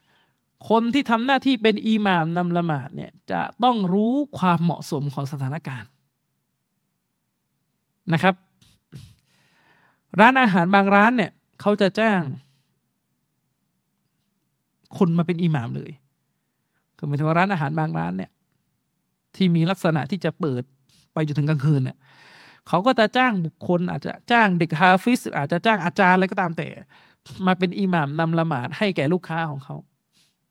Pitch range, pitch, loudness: 155-200 Hz, 175 Hz, -21 LUFS